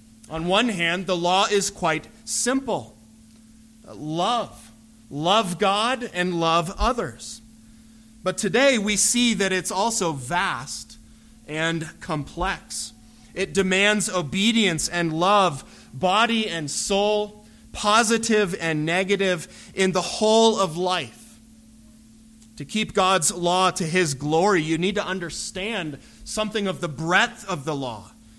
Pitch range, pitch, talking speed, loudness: 160-215 Hz, 185 Hz, 125 wpm, -22 LUFS